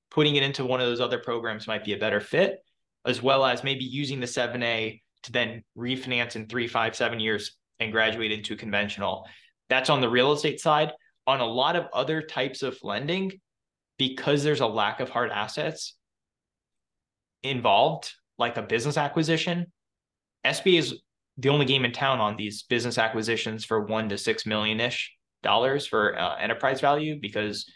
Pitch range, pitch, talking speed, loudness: 110-145 Hz, 125 Hz, 175 wpm, -26 LUFS